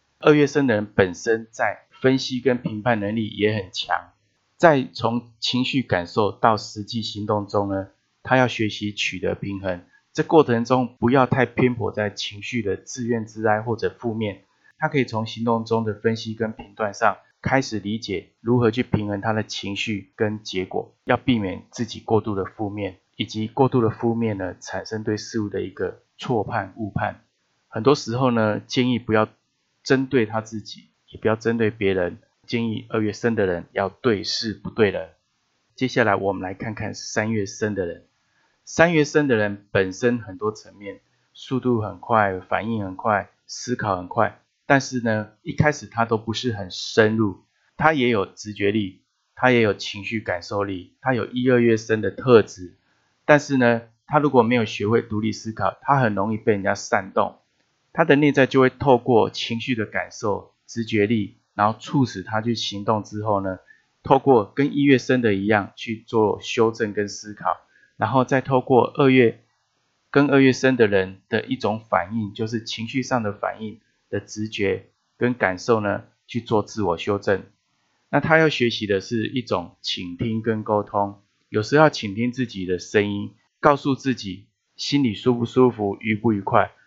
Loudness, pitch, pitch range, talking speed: -22 LUFS, 110 Hz, 105-125 Hz, 255 characters per minute